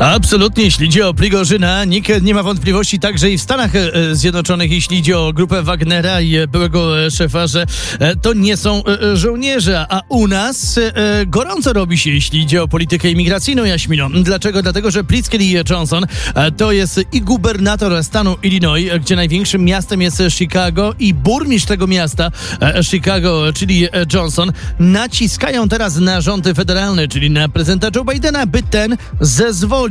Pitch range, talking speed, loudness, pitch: 170-205 Hz, 150 wpm, -13 LUFS, 185 Hz